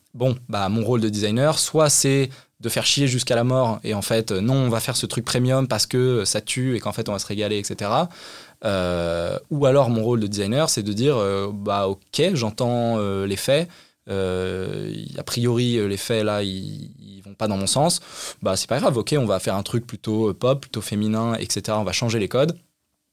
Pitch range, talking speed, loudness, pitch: 105-130 Hz, 220 wpm, -22 LUFS, 115 Hz